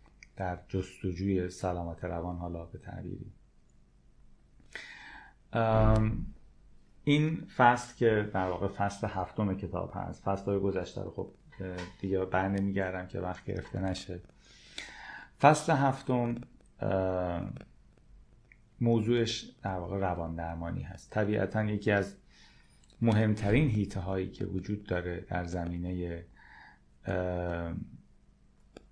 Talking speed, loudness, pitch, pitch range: 100 wpm, -32 LUFS, 95 Hz, 90-105 Hz